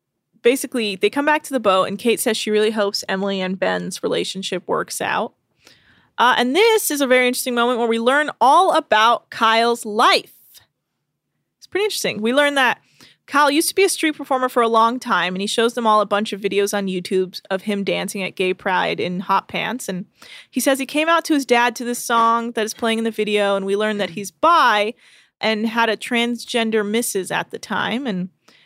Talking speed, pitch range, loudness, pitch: 220 wpm, 200-255 Hz, -19 LUFS, 225 Hz